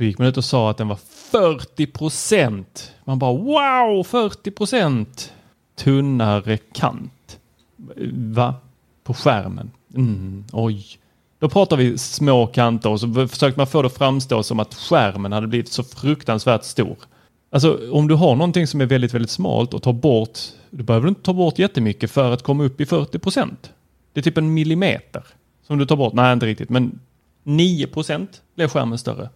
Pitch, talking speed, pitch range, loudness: 130 Hz, 175 wpm, 115-150 Hz, -19 LUFS